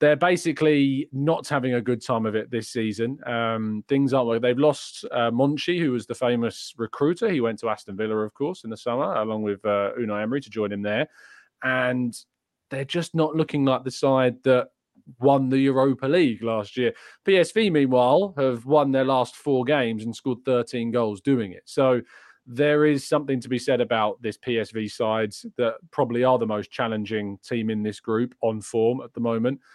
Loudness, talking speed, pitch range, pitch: -24 LUFS, 200 wpm, 110-135 Hz, 125 Hz